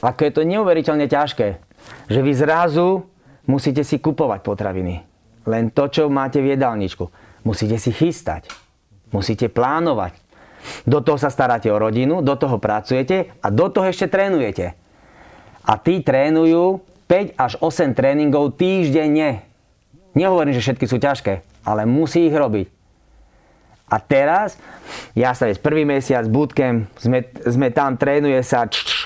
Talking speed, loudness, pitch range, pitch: 145 wpm, -18 LUFS, 115-155 Hz, 140 Hz